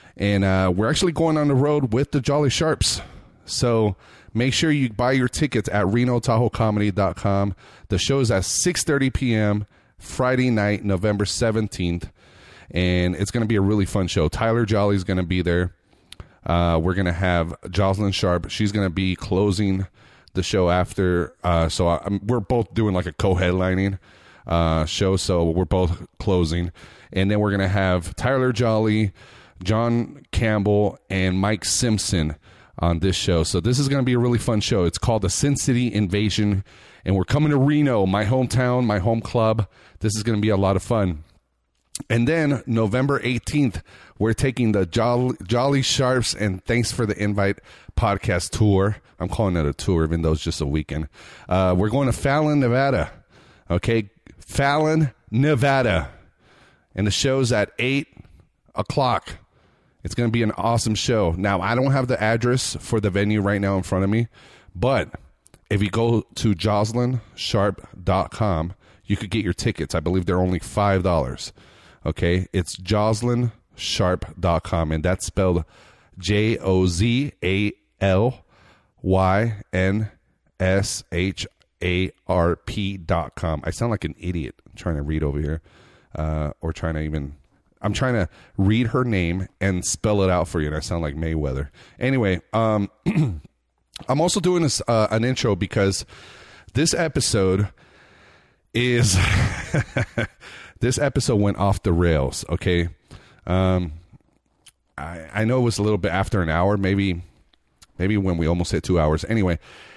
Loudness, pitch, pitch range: -22 LUFS, 100 Hz, 90-115 Hz